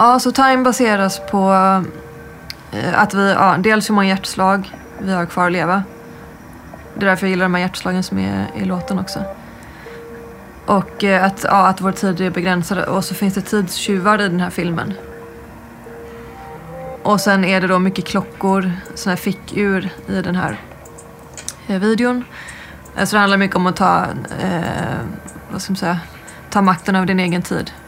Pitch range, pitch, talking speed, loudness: 180-200 Hz, 190 Hz, 170 wpm, -17 LUFS